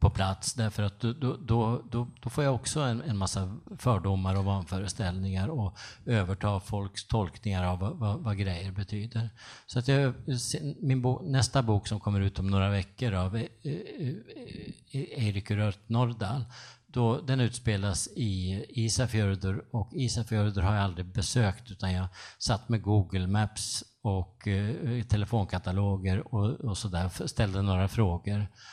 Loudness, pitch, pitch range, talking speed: -31 LUFS, 105 Hz, 100-120 Hz, 155 wpm